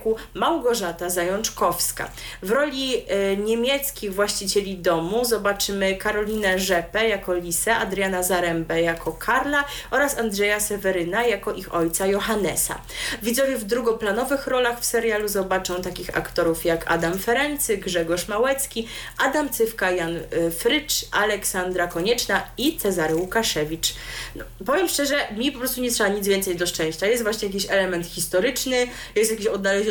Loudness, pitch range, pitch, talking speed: -23 LUFS, 180-235 Hz, 205 Hz, 130 wpm